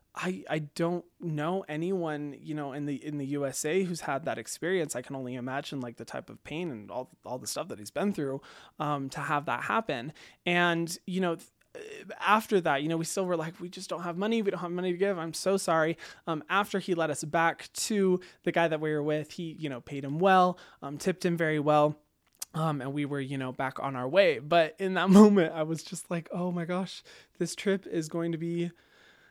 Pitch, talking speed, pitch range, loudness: 165 Hz, 235 wpm, 150-185 Hz, -30 LUFS